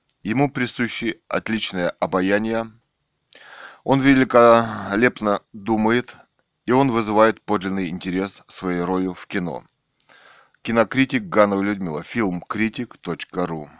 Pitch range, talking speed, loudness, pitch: 95-115 Hz, 95 wpm, -21 LUFS, 110 Hz